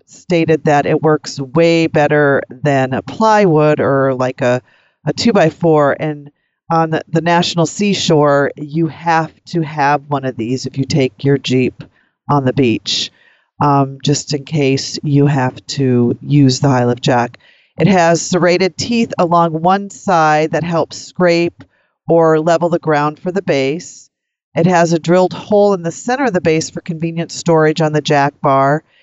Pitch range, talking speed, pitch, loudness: 140-170 Hz, 170 wpm, 155 Hz, -14 LUFS